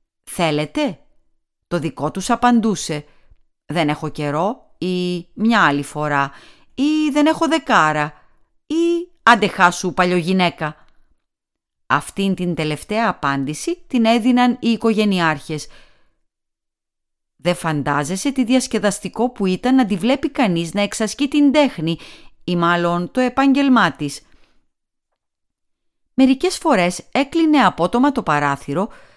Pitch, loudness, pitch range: 185 Hz, -18 LUFS, 155-255 Hz